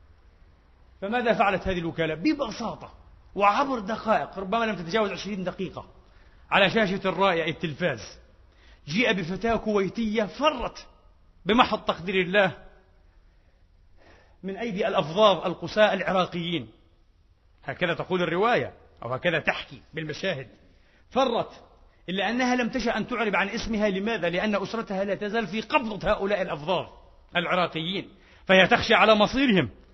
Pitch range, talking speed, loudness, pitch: 145-215 Hz, 115 wpm, -25 LUFS, 190 Hz